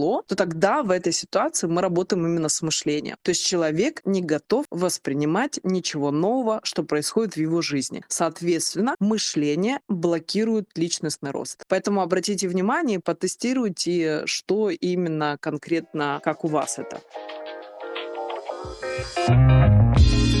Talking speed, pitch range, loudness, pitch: 115 wpm, 155-190 Hz, -23 LUFS, 175 Hz